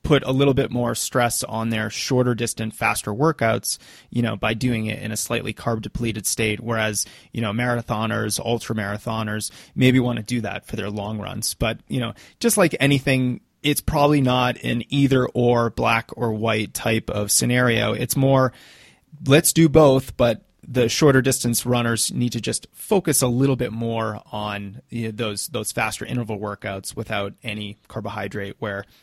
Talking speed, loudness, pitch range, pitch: 180 wpm, -21 LUFS, 110-130 Hz, 115 Hz